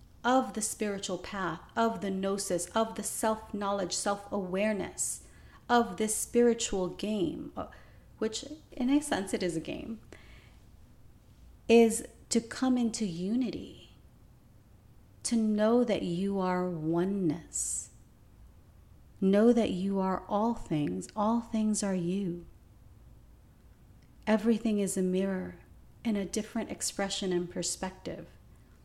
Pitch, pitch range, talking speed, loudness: 200 Hz, 180-225 Hz, 115 wpm, -31 LUFS